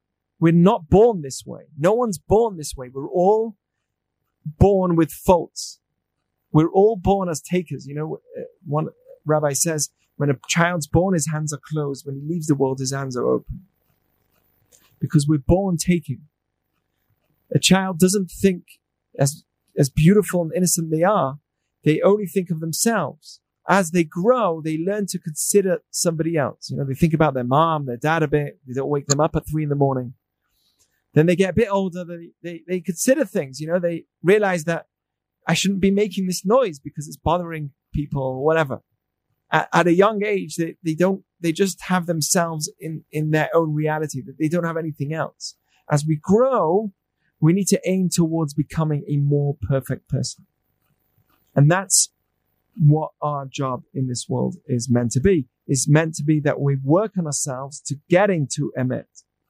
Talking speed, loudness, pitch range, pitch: 185 wpm, -21 LUFS, 145-180 Hz, 160 Hz